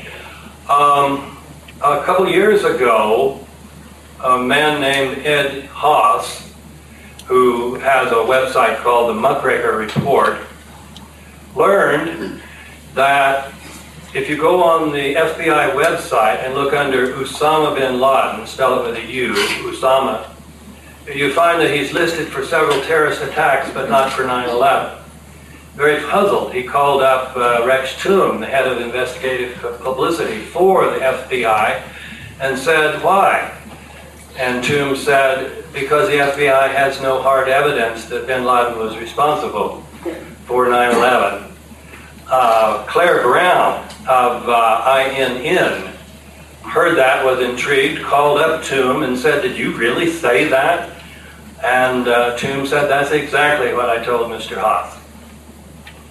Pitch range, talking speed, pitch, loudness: 95-140 Hz, 125 wpm, 130 Hz, -15 LUFS